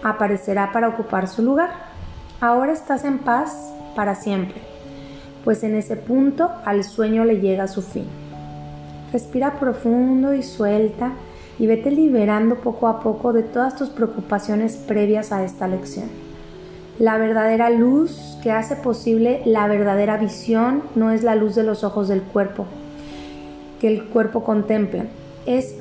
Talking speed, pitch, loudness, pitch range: 145 wpm, 220 Hz, -20 LUFS, 200-240 Hz